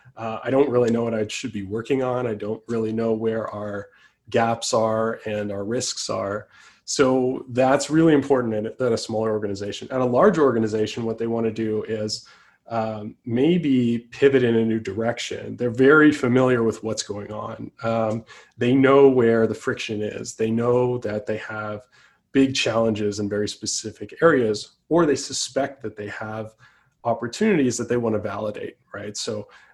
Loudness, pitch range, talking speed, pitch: -22 LUFS, 110-125 Hz, 190 wpm, 115 Hz